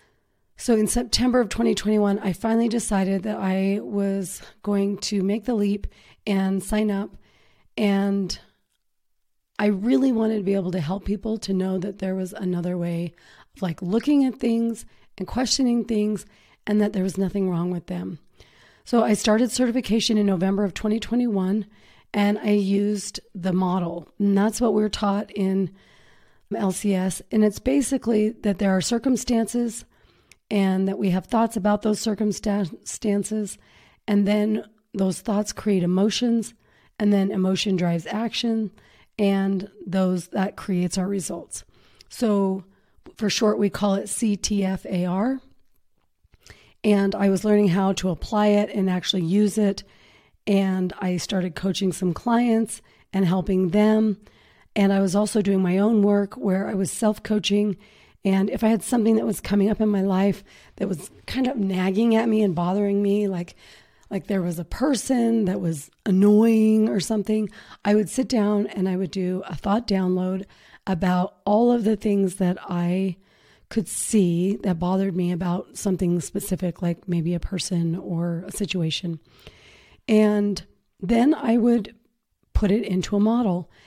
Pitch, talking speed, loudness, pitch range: 200 Hz, 155 wpm, -23 LUFS, 190-215 Hz